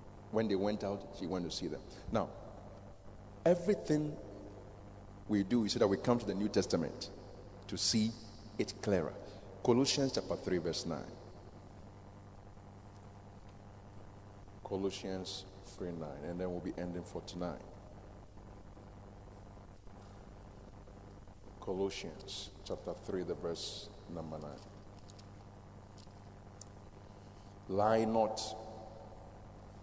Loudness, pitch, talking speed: -37 LUFS, 100 Hz, 100 wpm